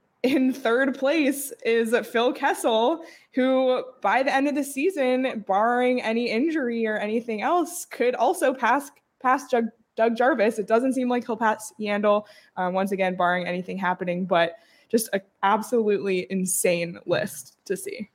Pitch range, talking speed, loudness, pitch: 205-265 Hz, 155 wpm, -24 LUFS, 235 Hz